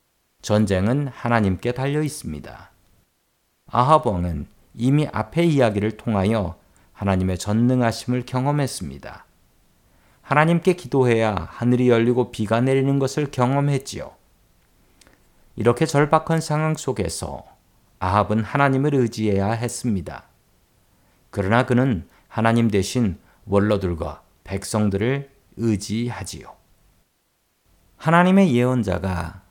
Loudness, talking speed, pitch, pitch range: -21 LUFS, 255 characters per minute, 115 Hz, 95-135 Hz